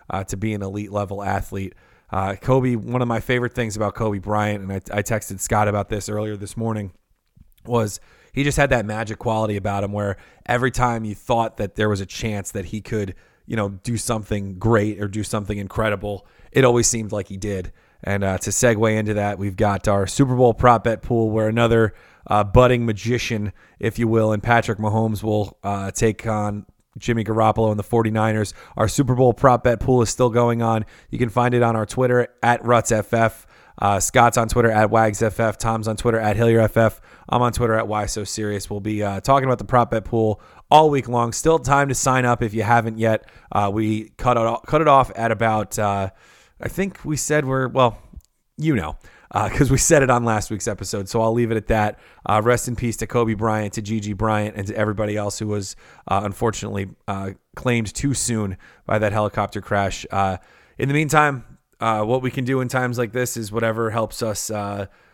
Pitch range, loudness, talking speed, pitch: 105-120 Hz, -21 LUFS, 215 wpm, 110 Hz